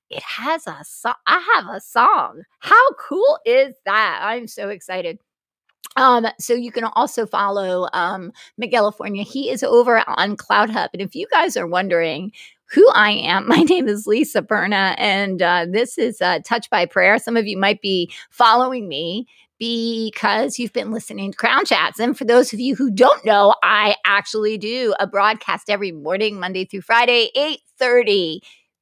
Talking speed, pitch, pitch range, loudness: 175 wpm, 220 Hz, 200-245 Hz, -17 LUFS